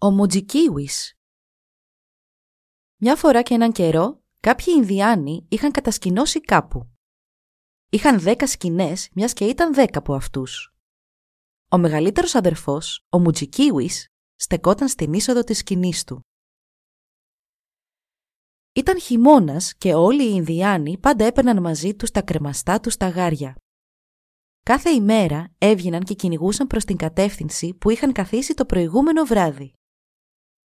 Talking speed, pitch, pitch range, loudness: 120 wpm, 200 Hz, 165-250 Hz, -19 LUFS